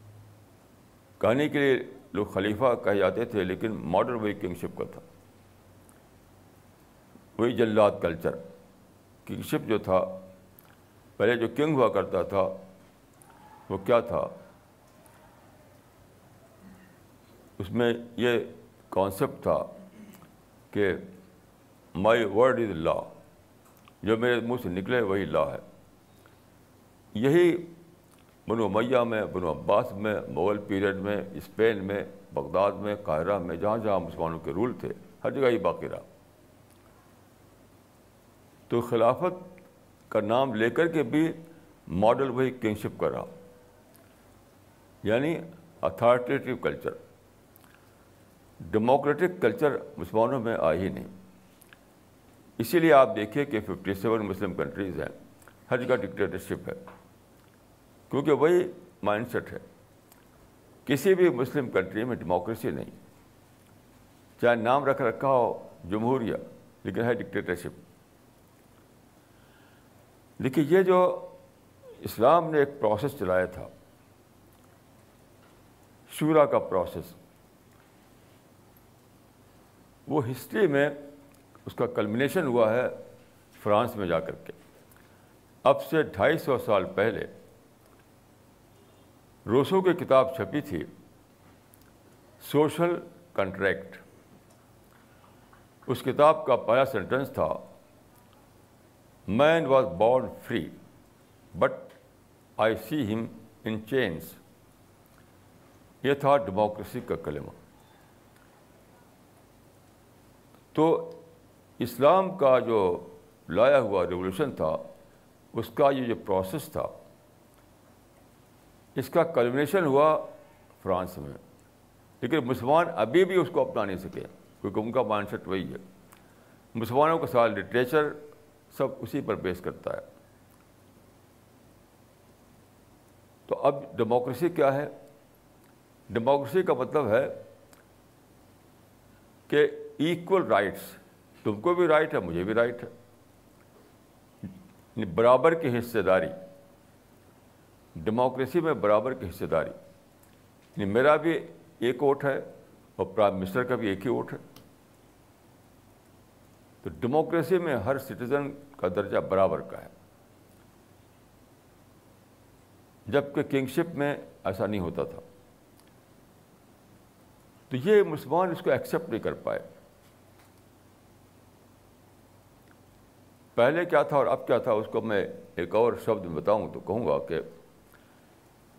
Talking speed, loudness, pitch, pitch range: 110 wpm, -27 LUFS, 120 Hz, 105-135 Hz